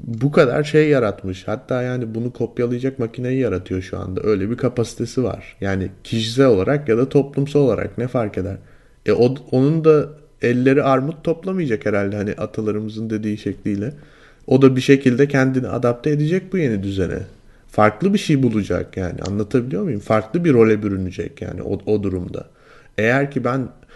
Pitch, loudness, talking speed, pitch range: 120 Hz, -19 LUFS, 165 wpm, 105-135 Hz